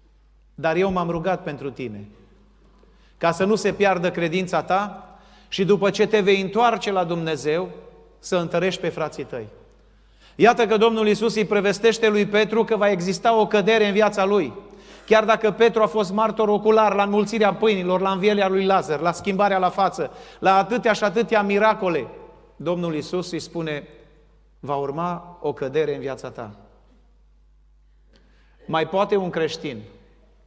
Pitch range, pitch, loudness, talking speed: 160-210 Hz, 190 Hz, -21 LUFS, 160 wpm